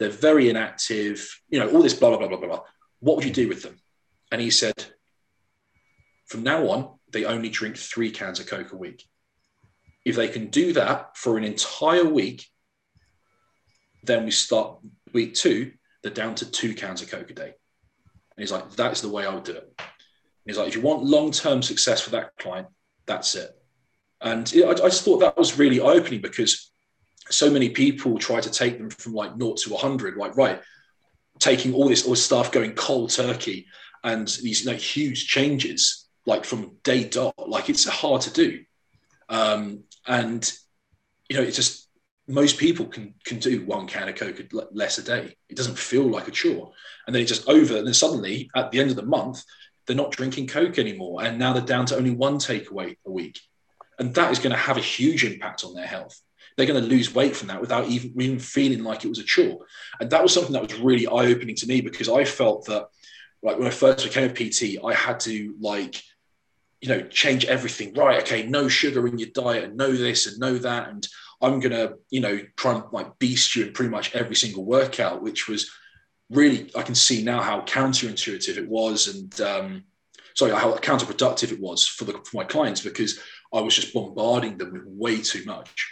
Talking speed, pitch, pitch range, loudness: 210 wpm, 130 Hz, 115-145 Hz, -23 LUFS